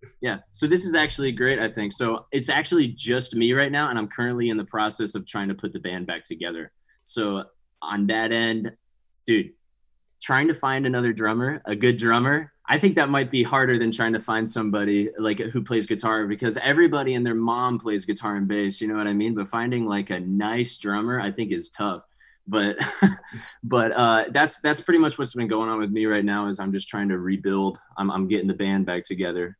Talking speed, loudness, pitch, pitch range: 220 wpm, -23 LUFS, 110 Hz, 100-125 Hz